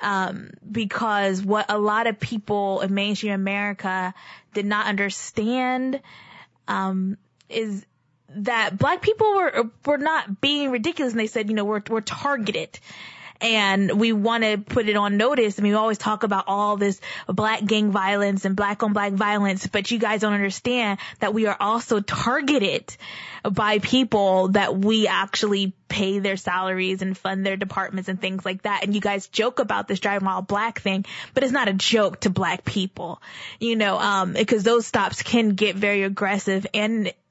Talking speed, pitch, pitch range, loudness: 180 wpm, 205 Hz, 195-225 Hz, -22 LUFS